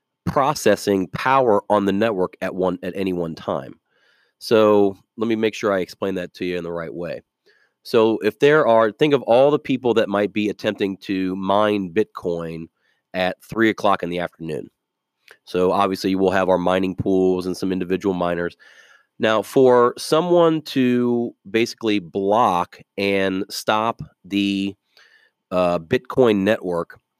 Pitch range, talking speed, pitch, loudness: 90-110 Hz, 155 wpm, 100 Hz, -20 LUFS